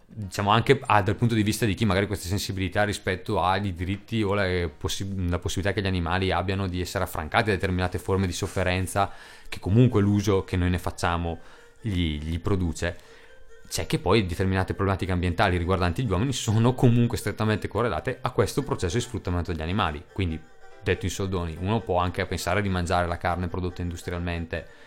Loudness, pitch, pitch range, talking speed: -26 LUFS, 95 Hz, 90-105 Hz, 185 wpm